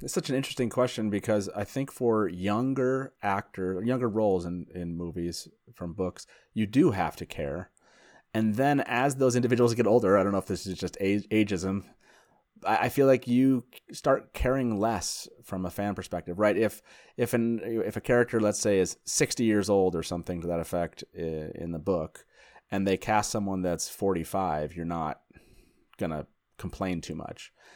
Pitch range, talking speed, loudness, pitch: 90-120 Hz, 180 wpm, -28 LUFS, 105 Hz